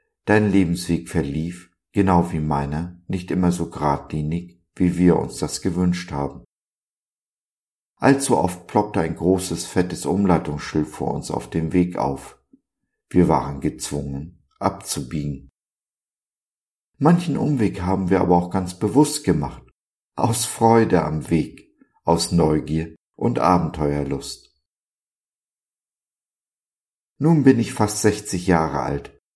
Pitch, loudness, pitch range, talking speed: 90 Hz, -21 LUFS, 80-100 Hz, 115 wpm